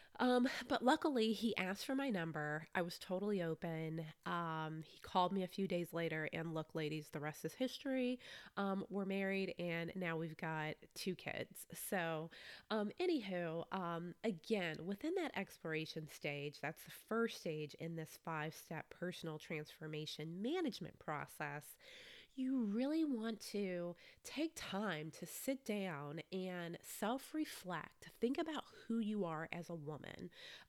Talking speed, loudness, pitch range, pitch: 150 wpm, -43 LUFS, 160-230 Hz, 180 Hz